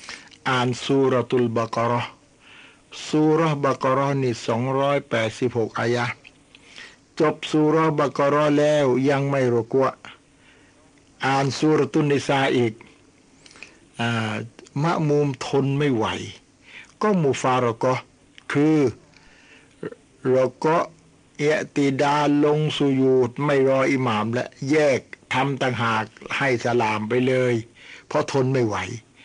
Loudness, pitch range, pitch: -22 LUFS, 120-145 Hz, 135 Hz